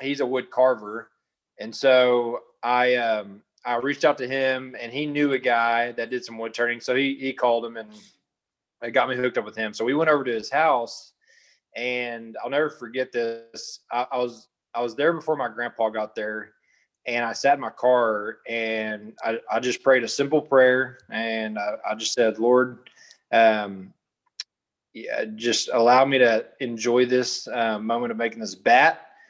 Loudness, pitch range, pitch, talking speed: -23 LUFS, 115-130 Hz, 120 Hz, 190 wpm